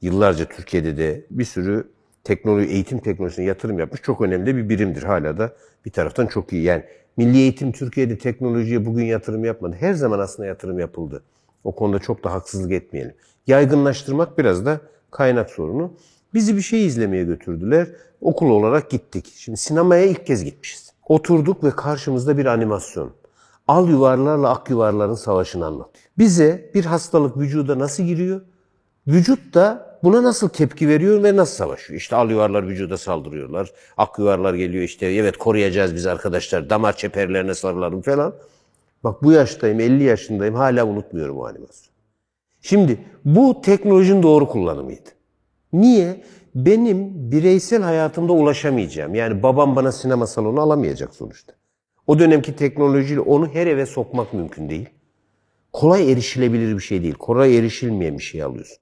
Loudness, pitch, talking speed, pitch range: -18 LUFS, 125 Hz, 145 wpm, 105-155 Hz